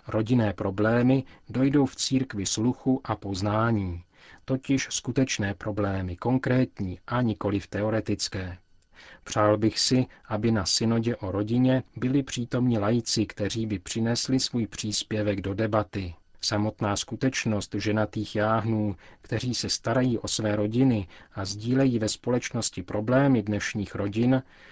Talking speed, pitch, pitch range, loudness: 125 wpm, 110 Hz, 100-125 Hz, -27 LUFS